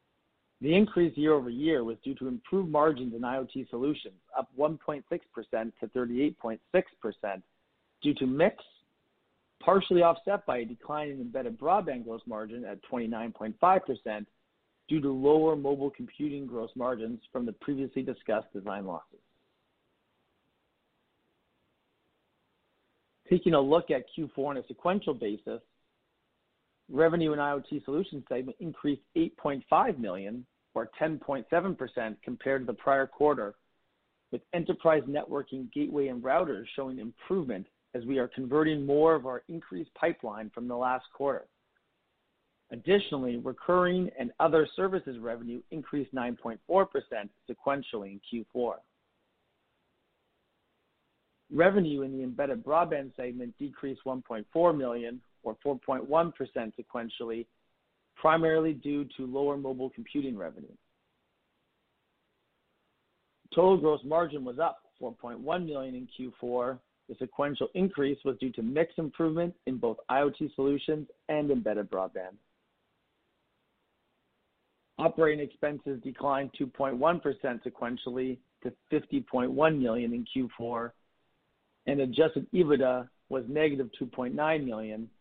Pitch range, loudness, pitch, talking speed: 125-155 Hz, -31 LUFS, 140 Hz, 115 wpm